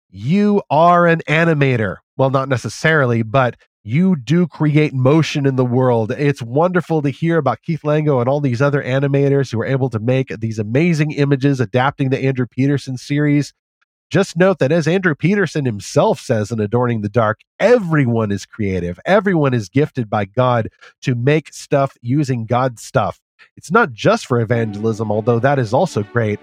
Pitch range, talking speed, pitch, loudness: 120-155 Hz, 175 wpm, 135 Hz, -17 LUFS